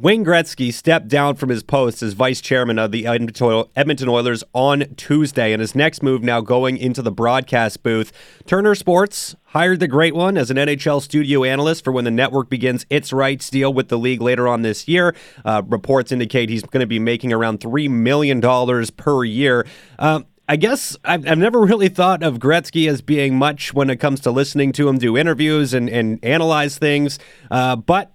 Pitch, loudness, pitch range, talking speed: 135 Hz, -17 LUFS, 120-150 Hz, 200 wpm